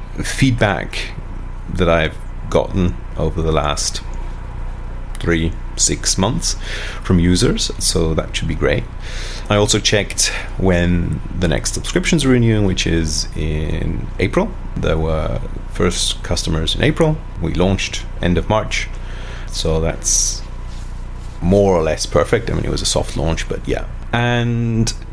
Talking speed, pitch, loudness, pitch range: 135 wpm, 90 Hz, -18 LUFS, 80-100 Hz